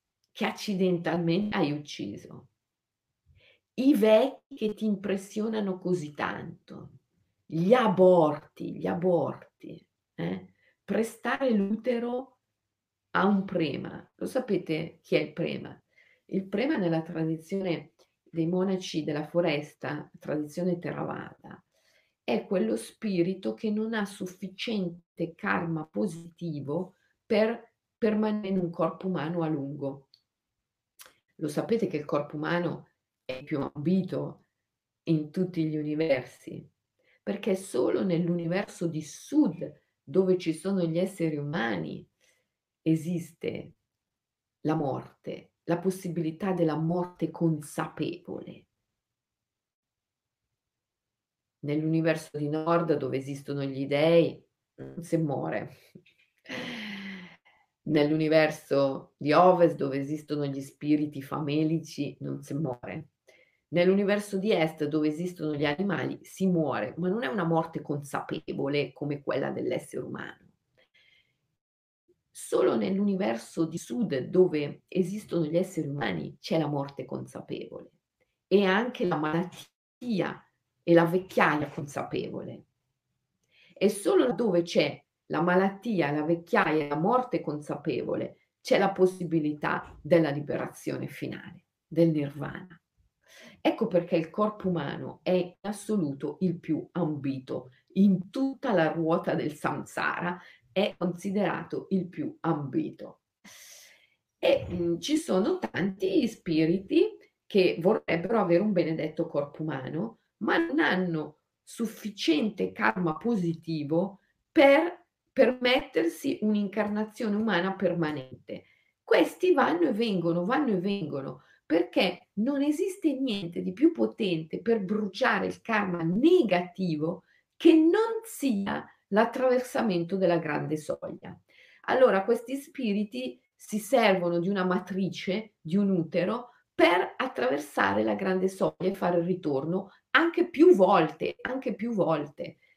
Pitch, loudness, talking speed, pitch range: 175 Hz, -28 LUFS, 110 wpm, 155-205 Hz